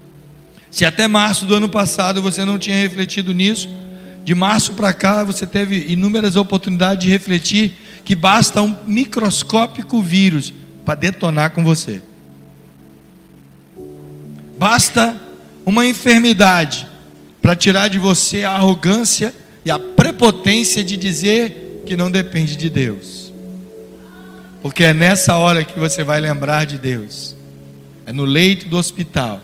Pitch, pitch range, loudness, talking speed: 185 Hz, 145-200 Hz, -15 LUFS, 130 wpm